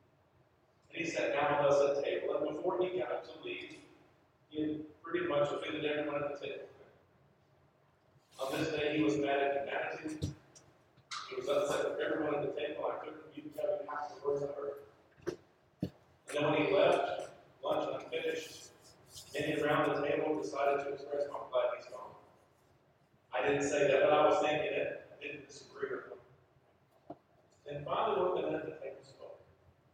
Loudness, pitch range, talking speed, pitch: -35 LUFS, 140-195 Hz, 175 wpm, 150 Hz